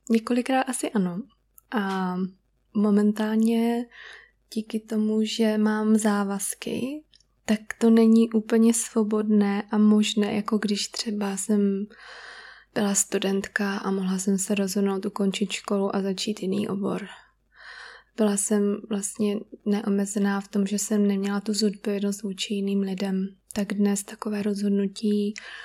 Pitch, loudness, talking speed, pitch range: 210 Hz, -25 LUFS, 120 wpm, 200-220 Hz